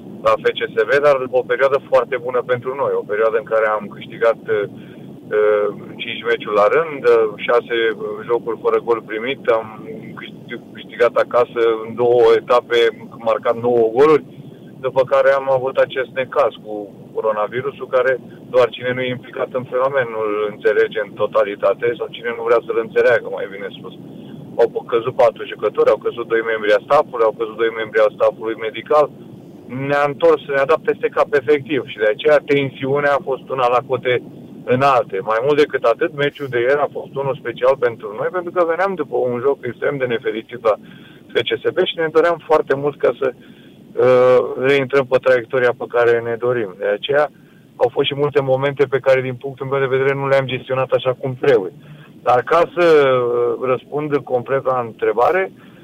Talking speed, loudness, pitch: 175 wpm, -17 LUFS, 165 Hz